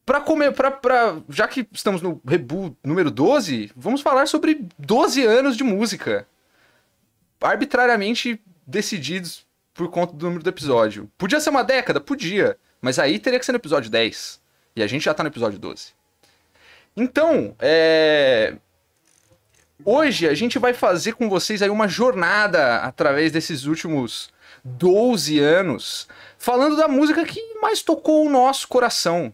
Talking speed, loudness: 150 wpm, -20 LUFS